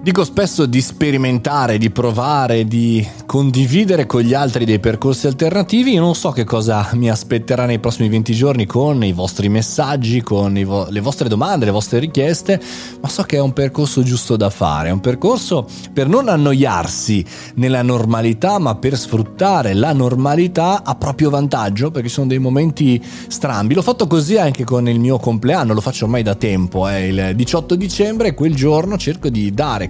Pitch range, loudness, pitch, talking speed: 115-150 Hz, -16 LUFS, 130 Hz, 185 wpm